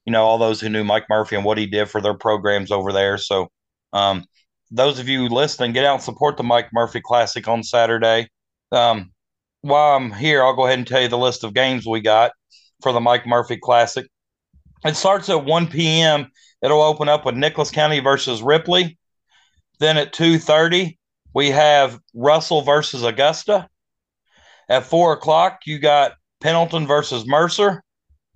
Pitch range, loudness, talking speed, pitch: 115-150 Hz, -18 LUFS, 175 wpm, 130 Hz